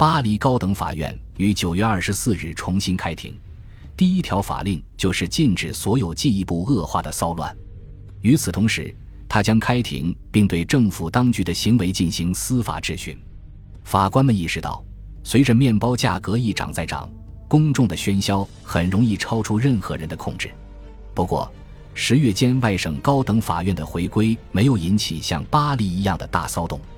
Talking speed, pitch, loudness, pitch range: 260 characters per minute, 100 Hz, -21 LUFS, 90-115 Hz